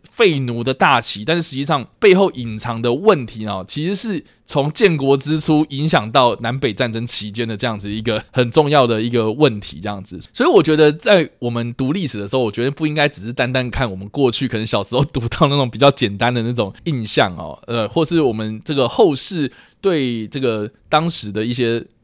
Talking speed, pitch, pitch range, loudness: 320 characters per minute, 125 Hz, 110-150 Hz, -17 LUFS